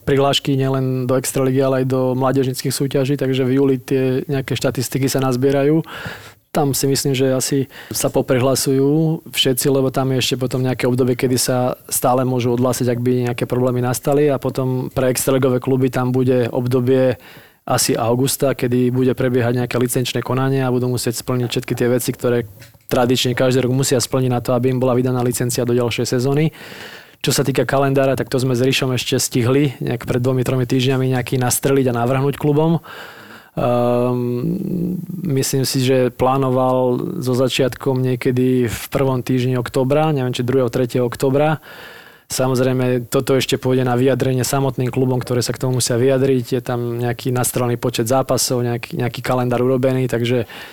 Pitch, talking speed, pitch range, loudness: 130 Hz, 170 wpm, 125-135 Hz, -18 LUFS